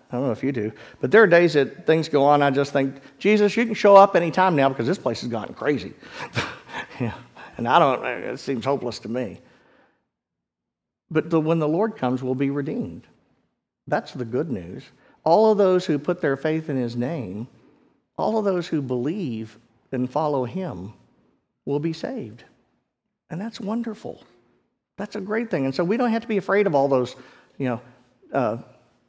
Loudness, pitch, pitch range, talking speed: -22 LUFS, 150 Hz, 130-195 Hz, 200 wpm